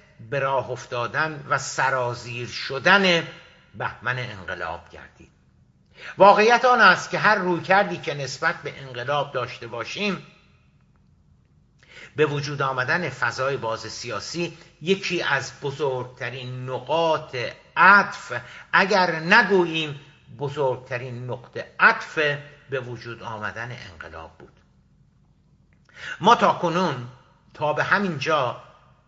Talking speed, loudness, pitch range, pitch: 100 wpm, -22 LUFS, 125-165 Hz, 140 Hz